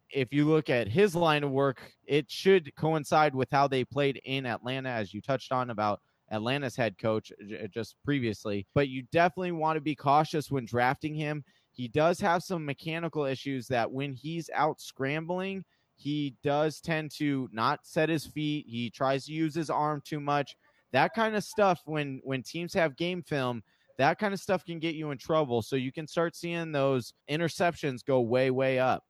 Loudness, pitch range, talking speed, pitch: -30 LUFS, 130-160 Hz, 195 wpm, 145 Hz